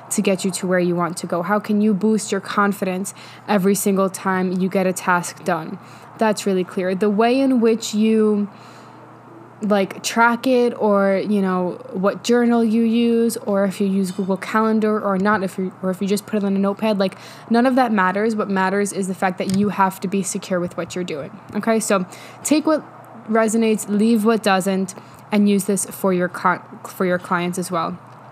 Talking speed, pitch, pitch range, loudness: 210 wpm, 200 Hz, 190-220 Hz, -19 LUFS